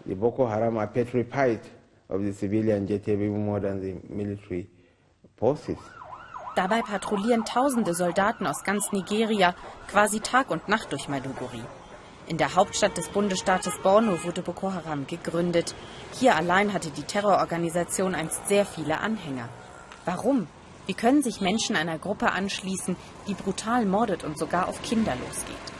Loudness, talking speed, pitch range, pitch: -26 LUFS, 110 wpm, 120-205 Hz, 175 Hz